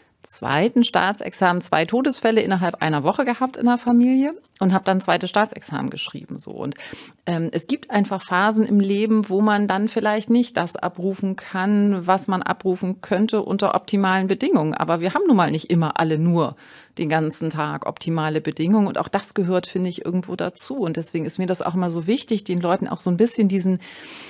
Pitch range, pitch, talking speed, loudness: 175-215 Hz, 190 Hz, 195 wpm, -21 LUFS